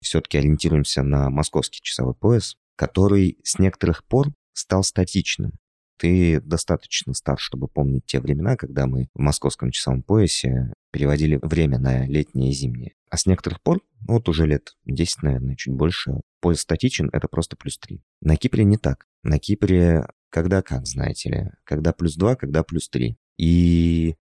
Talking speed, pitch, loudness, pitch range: 160 wpm, 80 Hz, -22 LUFS, 70-90 Hz